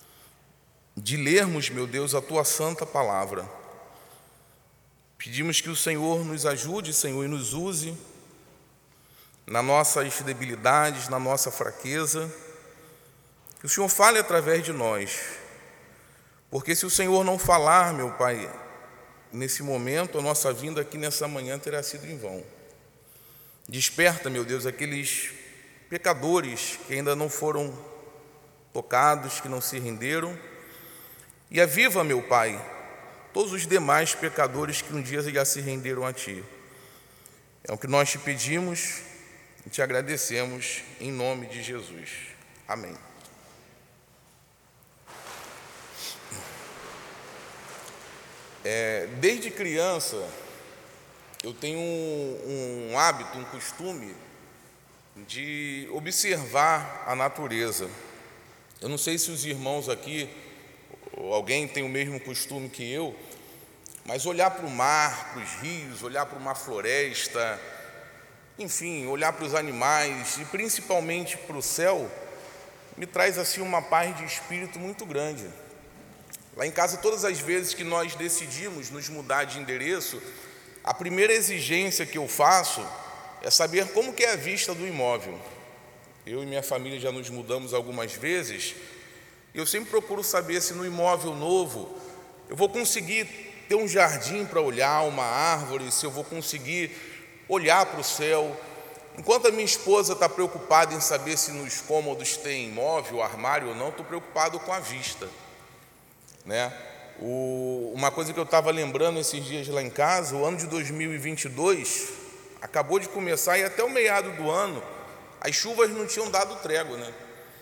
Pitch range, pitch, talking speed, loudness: 135-175 Hz, 150 Hz, 140 wpm, -26 LUFS